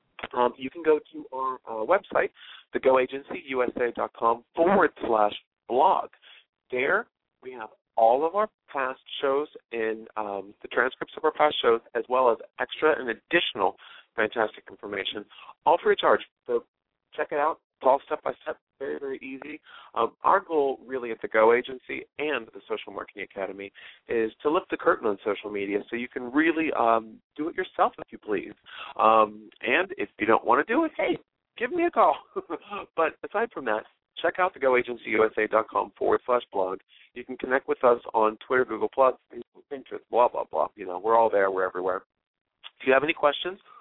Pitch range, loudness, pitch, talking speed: 110-165 Hz, -26 LUFS, 130 Hz, 185 wpm